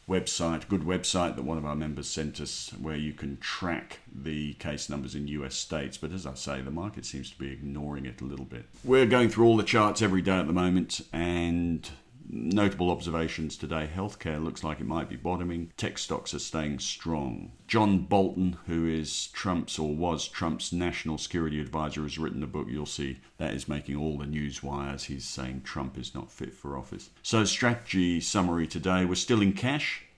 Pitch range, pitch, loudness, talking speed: 70-90 Hz, 80 Hz, -30 LUFS, 200 wpm